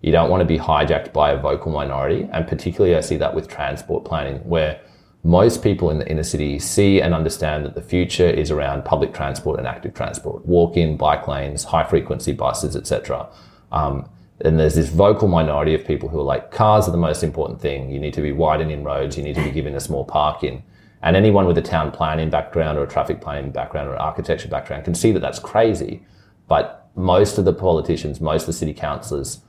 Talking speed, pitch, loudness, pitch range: 220 wpm, 80 Hz, -20 LUFS, 75-90 Hz